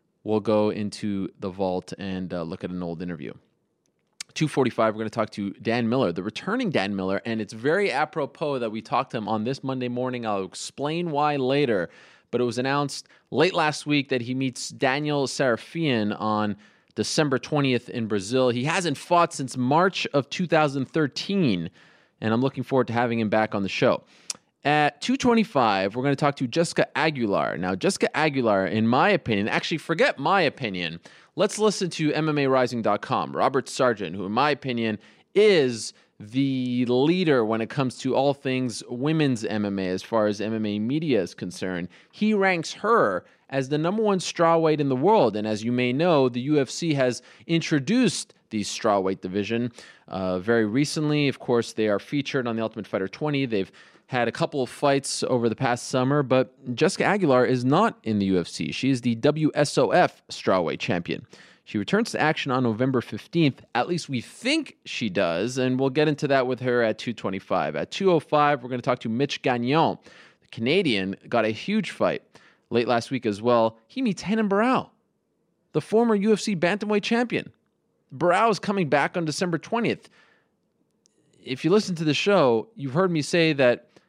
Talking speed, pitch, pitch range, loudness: 180 wpm, 130 Hz, 110-155 Hz, -24 LUFS